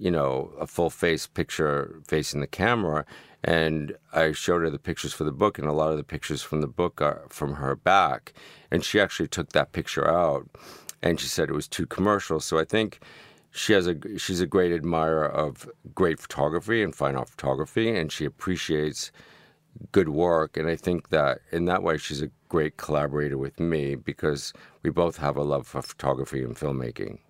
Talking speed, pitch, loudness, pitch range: 200 wpm, 75 Hz, -26 LUFS, 70-85 Hz